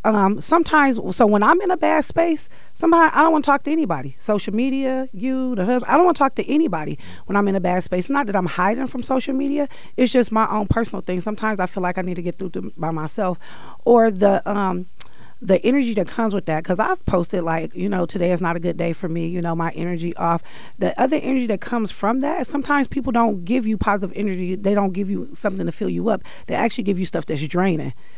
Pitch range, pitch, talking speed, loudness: 180-260 Hz, 210 Hz, 245 wpm, -20 LUFS